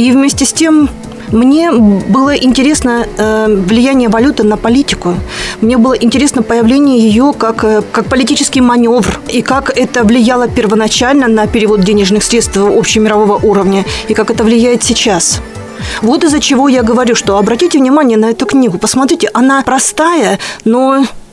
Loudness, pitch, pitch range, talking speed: -9 LUFS, 240 Hz, 220-265 Hz, 145 wpm